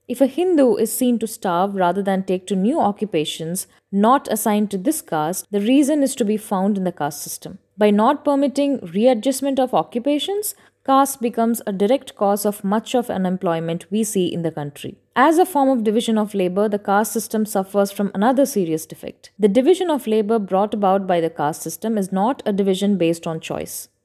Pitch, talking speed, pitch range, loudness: 210 Hz, 200 wpm, 185-250 Hz, -19 LUFS